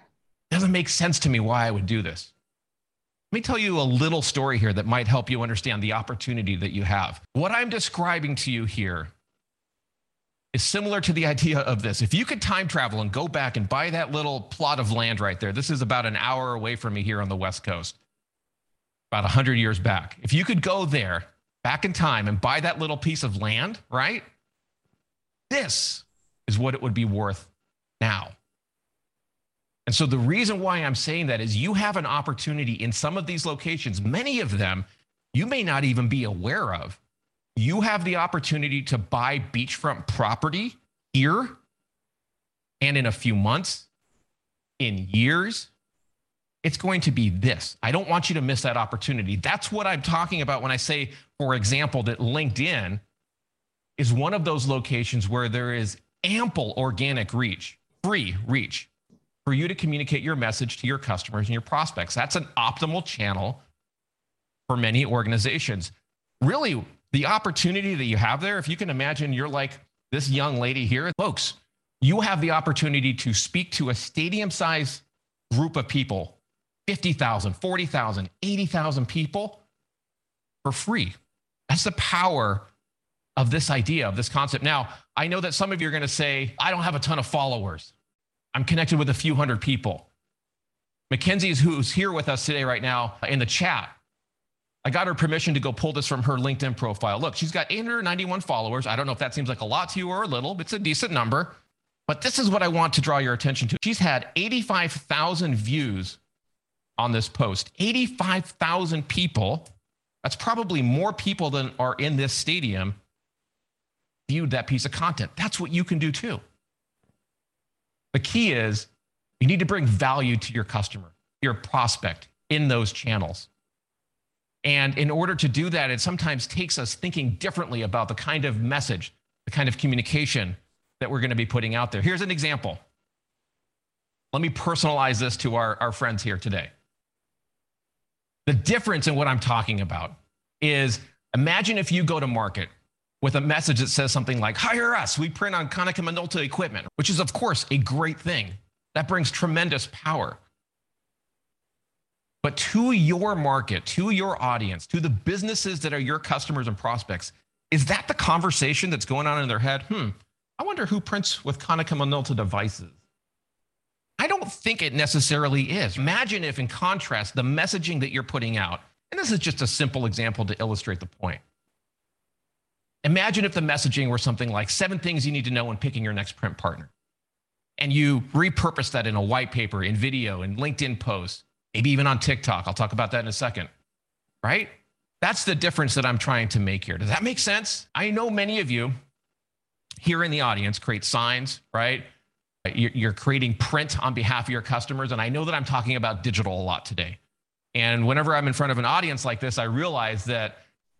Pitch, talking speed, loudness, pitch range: 135 Hz, 185 wpm, -25 LUFS, 115-160 Hz